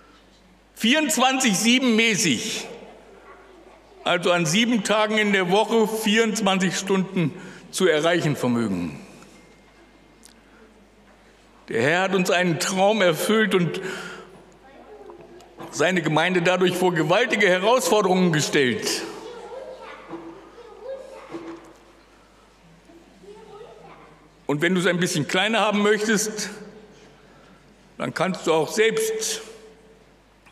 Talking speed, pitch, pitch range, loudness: 85 wpm, 210 Hz, 180-225 Hz, -21 LUFS